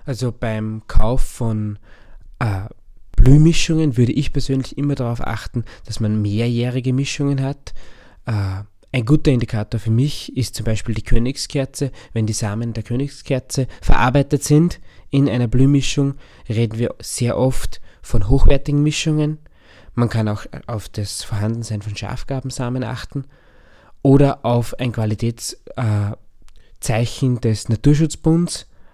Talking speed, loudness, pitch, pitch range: 125 wpm, -20 LUFS, 120 Hz, 110-135 Hz